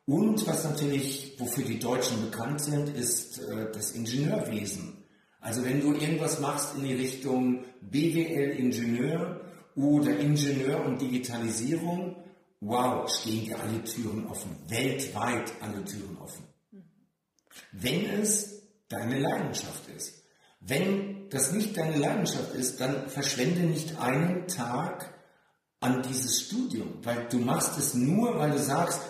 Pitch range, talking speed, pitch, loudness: 125-170 Hz, 125 wpm, 140 Hz, -30 LUFS